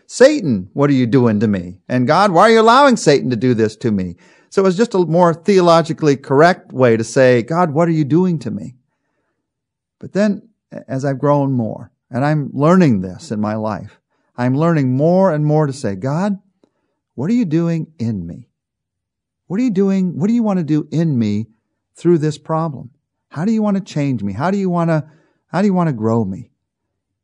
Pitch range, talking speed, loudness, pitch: 120-180 Hz, 215 wpm, -15 LUFS, 150 Hz